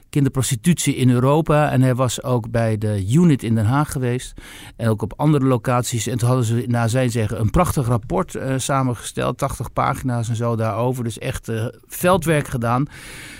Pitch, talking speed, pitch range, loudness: 125 Hz, 195 wpm, 115-135 Hz, -20 LUFS